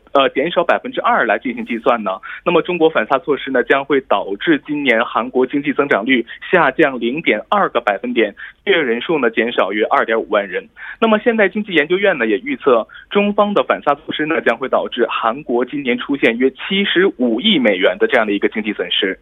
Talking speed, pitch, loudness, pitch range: 330 characters per minute, 215 Hz, -16 LUFS, 175-285 Hz